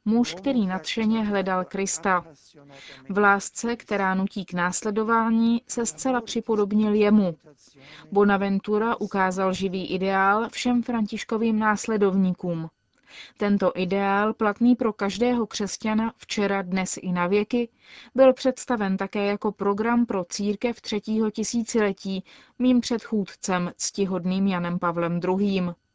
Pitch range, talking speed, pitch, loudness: 190-225 Hz, 110 wpm, 205 Hz, -24 LUFS